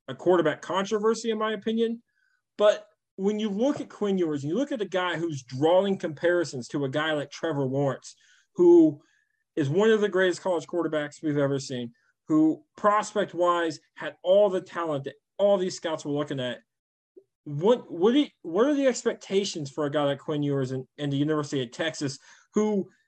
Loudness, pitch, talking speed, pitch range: -26 LUFS, 180 Hz, 190 wpm, 150-220 Hz